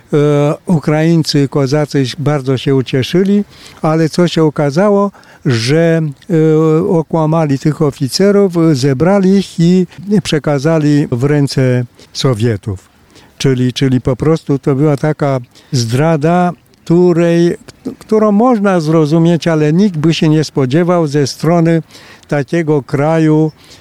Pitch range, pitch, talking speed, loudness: 140-170 Hz, 155 Hz, 105 wpm, -12 LUFS